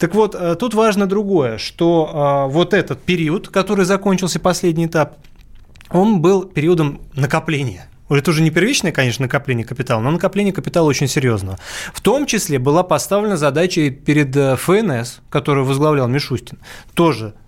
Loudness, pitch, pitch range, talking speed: -16 LUFS, 155 Hz, 135-185 Hz, 140 wpm